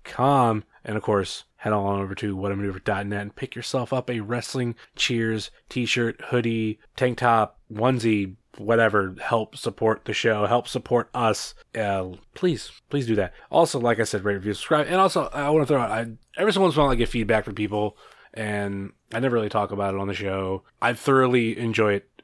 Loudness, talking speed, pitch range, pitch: -24 LUFS, 200 wpm, 105-125 Hz, 115 Hz